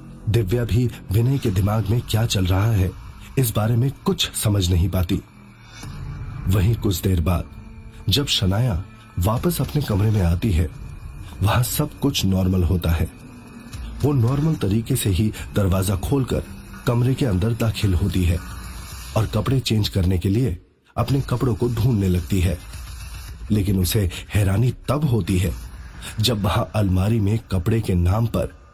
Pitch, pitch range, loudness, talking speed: 105 Hz, 95-115 Hz, -21 LUFS, 160 wpm